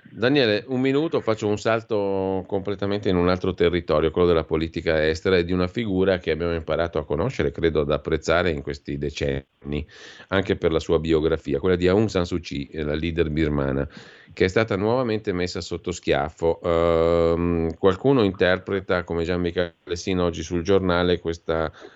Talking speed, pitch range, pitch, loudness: 170 wpm, 80-95 Hz, 85 Hz, -23 LUFS